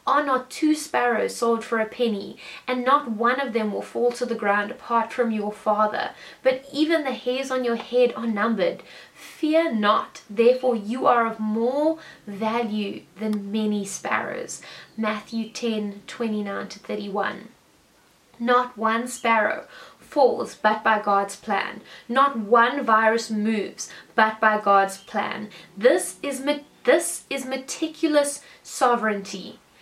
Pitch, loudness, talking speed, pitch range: 230 Hz, -23 LUFS, 135 wpm, 215-255 Hz